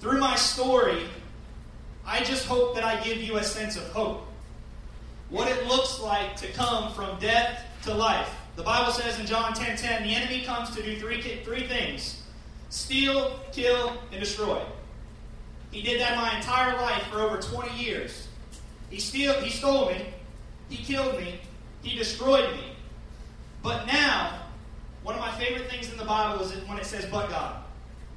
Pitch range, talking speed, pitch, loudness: 215-250 Hz, 170 wpm, 235 Hz, -27 LUFS